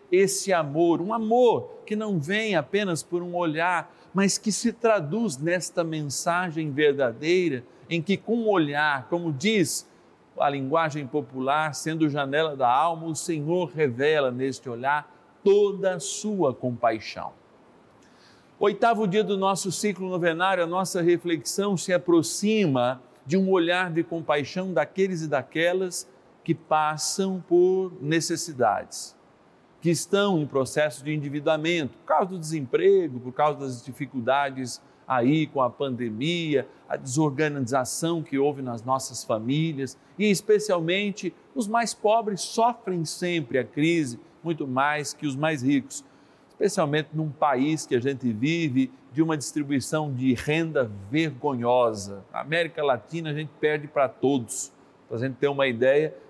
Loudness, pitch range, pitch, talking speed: -25 LUFS, 140-185 Hz, 160 Hz, 140 wpm